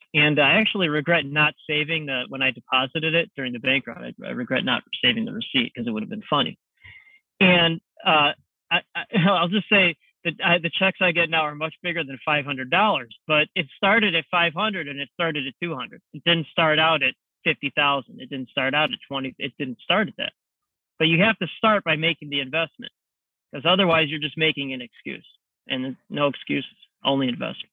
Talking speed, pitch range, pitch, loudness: 205 wpm, 140-180 Hz, 160 Hz, -22 LUFS